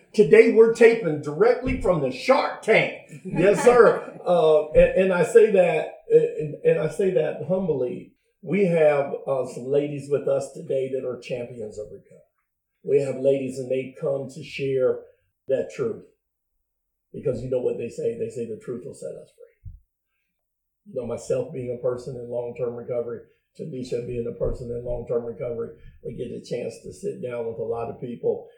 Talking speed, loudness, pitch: 185 wpm, -23 LUFS, 225 Hz